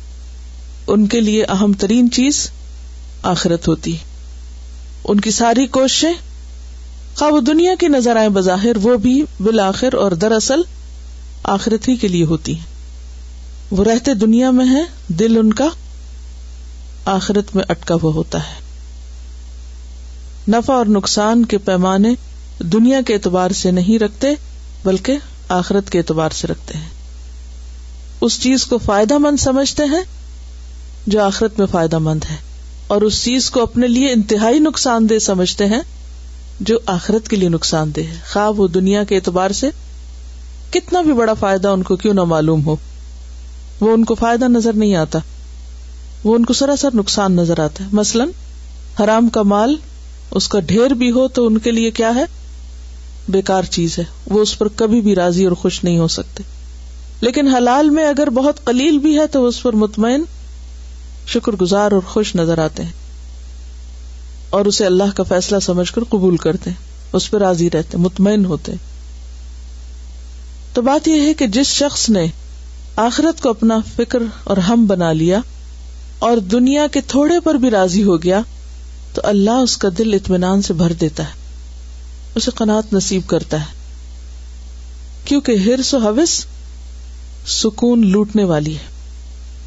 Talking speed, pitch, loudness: 155 wpm, 185 Hz, -15 LUFS